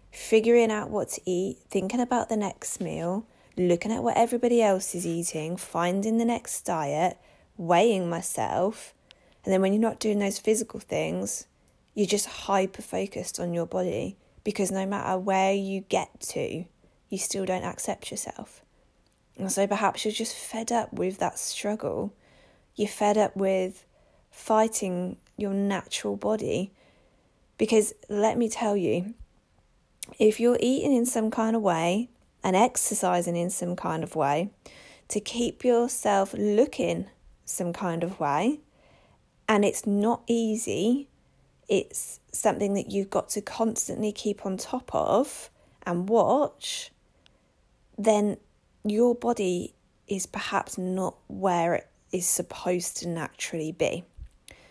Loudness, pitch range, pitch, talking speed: -27 LUFS, 185-225 Hz, 205 Hz, 140 wpm